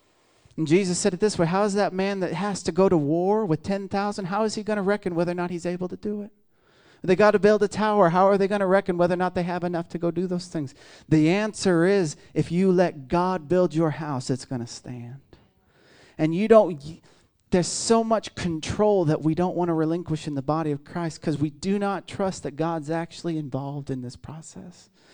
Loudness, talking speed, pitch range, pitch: -24 LUFS, 240 wpm, 155-195 Hz, 175 Hz